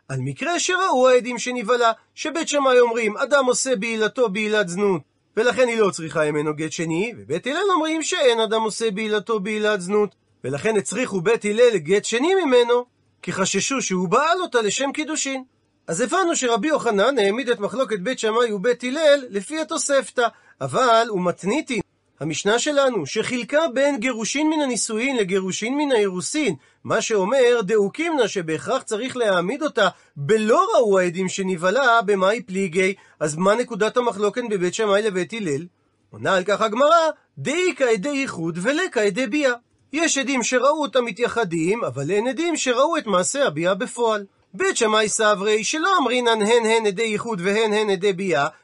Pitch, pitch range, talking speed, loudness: 225 Hz, 200-260 Hz, 155 wpm, -21 LUFS